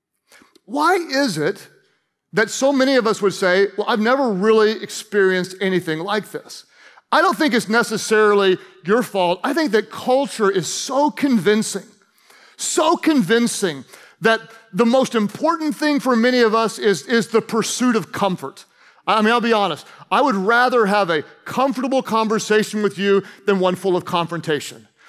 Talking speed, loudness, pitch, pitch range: 165 wpm, -18 LUFS, 220 Hz, 195-250 Hz